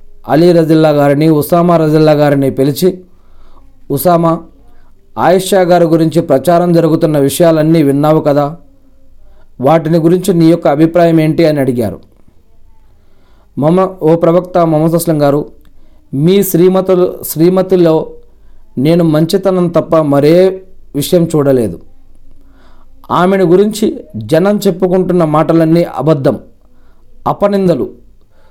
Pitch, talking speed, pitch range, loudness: 160 Hz, 95 wpm, 125-175 Hz, -10 LUFS